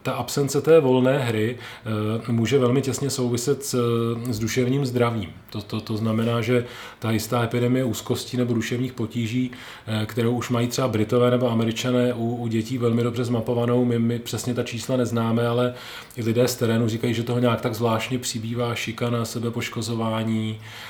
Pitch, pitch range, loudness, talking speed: 120 Hz, 115-125 Hz, -23 LUFS, 170 wpm